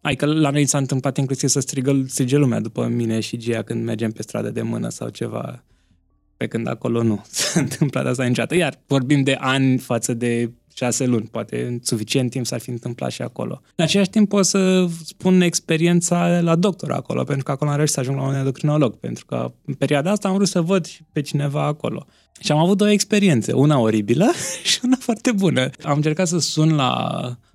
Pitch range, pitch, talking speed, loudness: 120-170 Hz, 140 Hz, 205 wpm, -20 LUFS